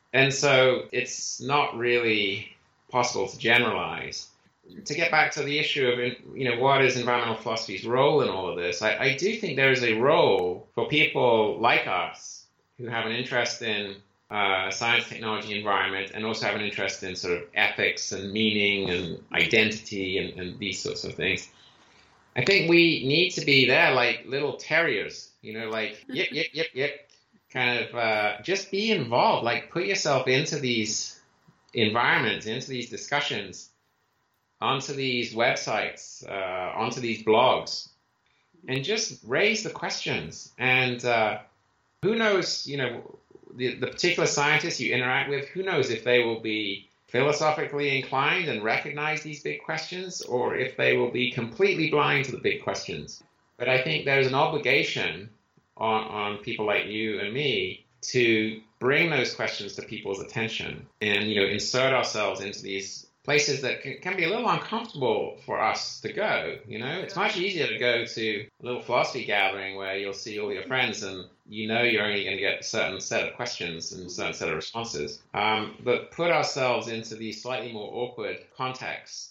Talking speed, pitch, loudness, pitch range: 175 wpm, 120 Hz, -25 LUFS, 105-140 Hz